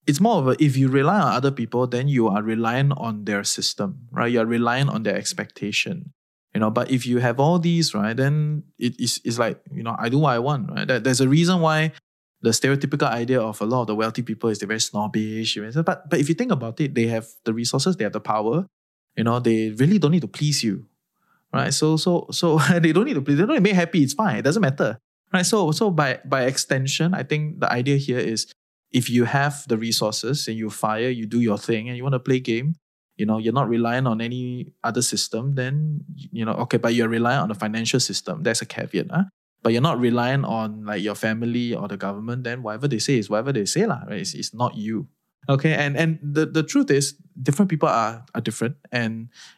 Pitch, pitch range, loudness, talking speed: 125 Hz, 115-150 Hz, -22 LUFS, 245 wpm